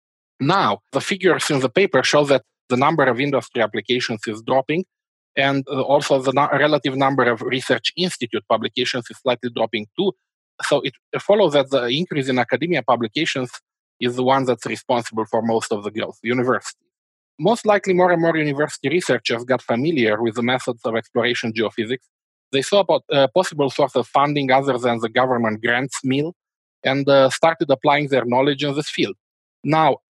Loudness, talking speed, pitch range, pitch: -19 LUFS, 175 wpm, 125-150 Hz, 135 Hz